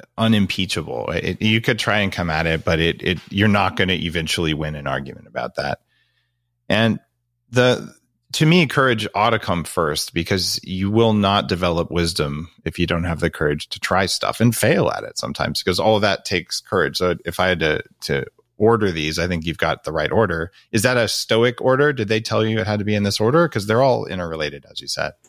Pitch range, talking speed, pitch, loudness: 85-110 Hz, 225 wpm, 100 Hz, -20 LUFS